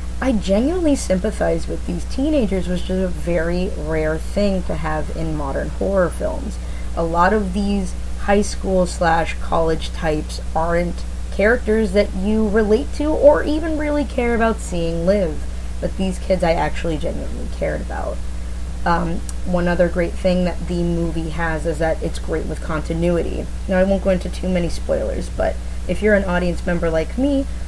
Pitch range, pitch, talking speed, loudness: 165-205 Hz, 180 Hz, 170 wpm, -20 LUFS